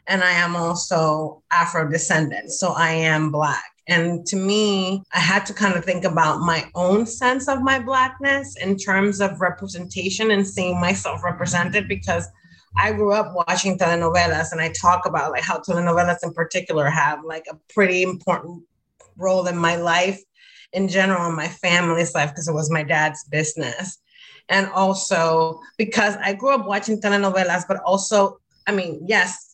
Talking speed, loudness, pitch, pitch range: 170 wpm, -20 LUFS, 180 Hz, 170-195 Hz